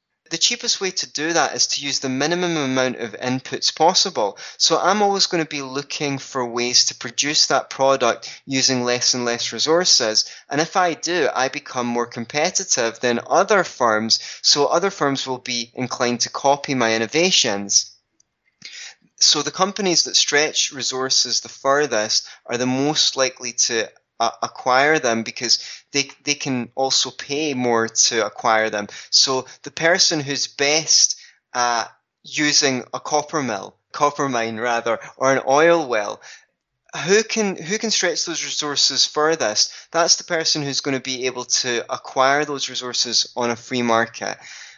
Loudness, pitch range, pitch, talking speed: -19 LUFS, 120-155 Hz, 135 Hz, 160 wpm